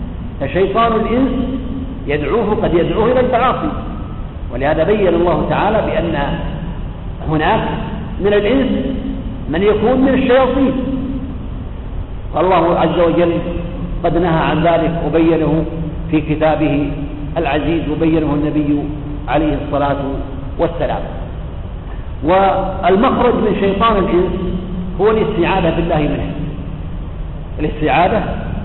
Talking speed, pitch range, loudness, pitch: 90 wpm, 145-200 Hz, -16 LUFS, 165 Hz